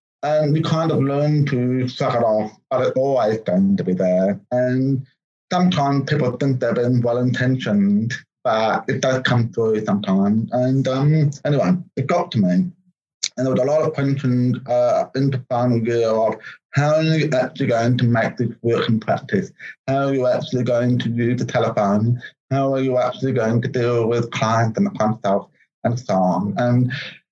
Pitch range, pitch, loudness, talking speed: 115-140 Hz, 125 Hz, -19 LUFS, 185 wpm